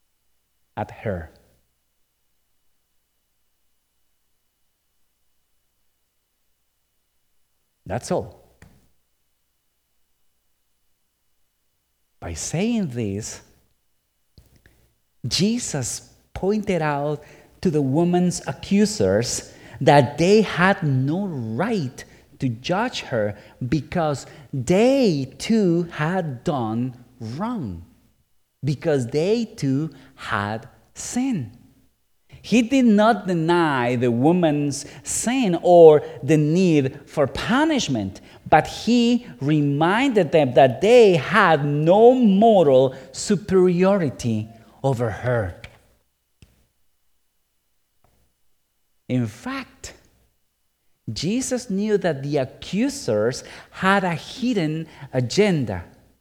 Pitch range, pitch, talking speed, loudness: 110-180 Hz, 145 Hz, 75 wpm, -20 LUFS